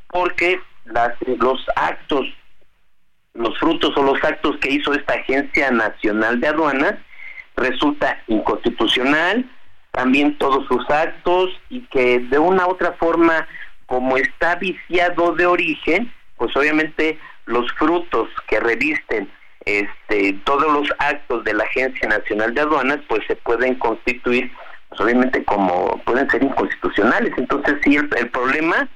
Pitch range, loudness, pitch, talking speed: 125-185 Hz, -18 LUFS, 160 Hz, 135 wpm